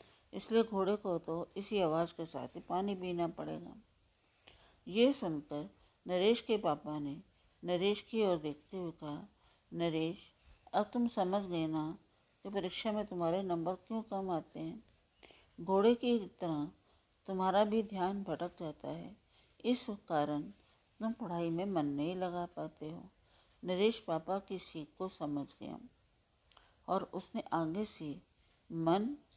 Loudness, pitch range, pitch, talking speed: -37 LUFS, 160-200 Hz, 180 Hz, 145 wpm